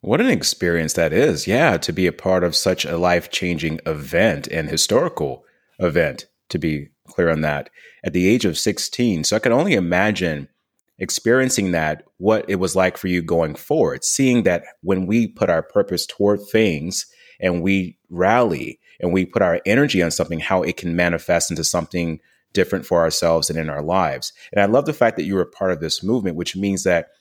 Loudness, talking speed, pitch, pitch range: -19 LUFS, 205 wpm, 90 Hz, 80-95 Hz